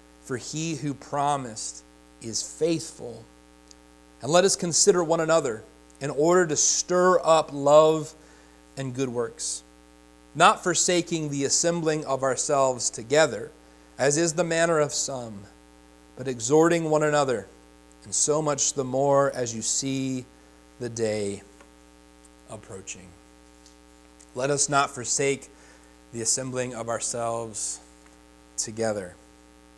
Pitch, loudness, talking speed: 120 Hz, -24 LUFS, 115 wpm